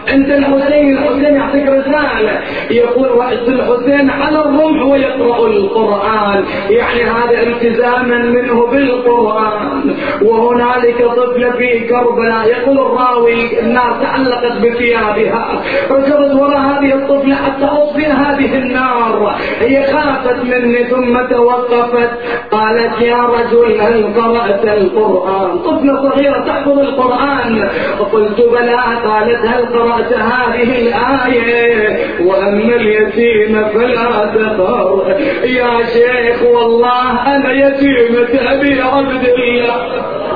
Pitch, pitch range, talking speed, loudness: 240 Hz, 235-270 Hz, 105 wpm, -11 LUFS